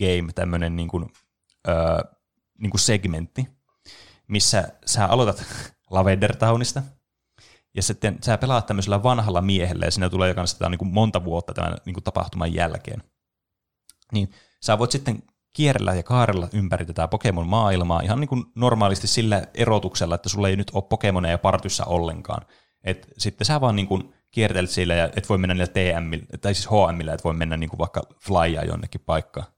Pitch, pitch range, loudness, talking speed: 95 Hz, 90-110 Hz, -23 LUFS, 170 wpm